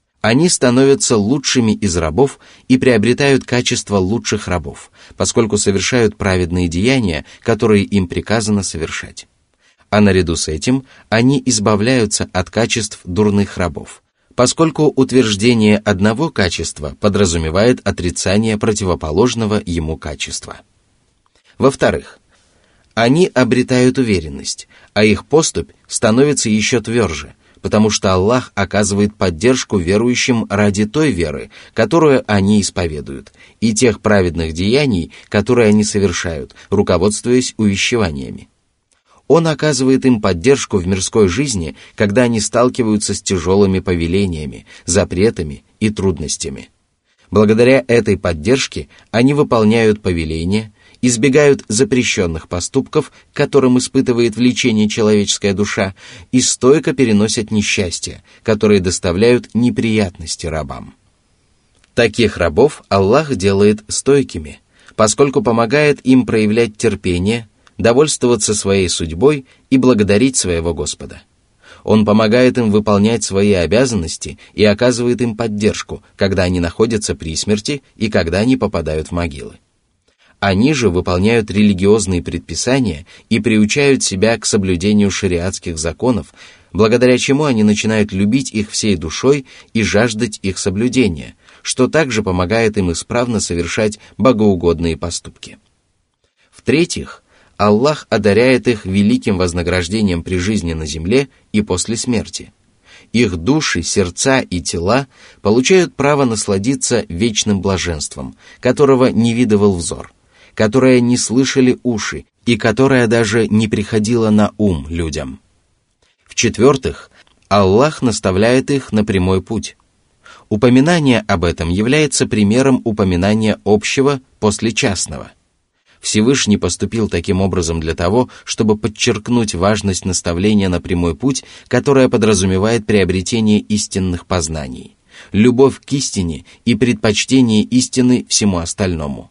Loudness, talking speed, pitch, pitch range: -14 LUFS, 110 wpm, 105 Hz, 95-125 Hz